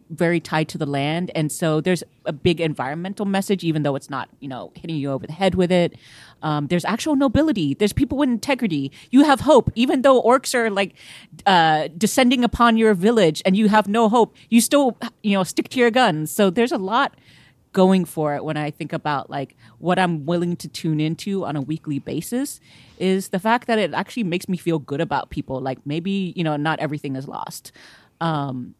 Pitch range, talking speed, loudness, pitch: 150-220 Hz, 215 wpm, -20 LUFS, 175 Hz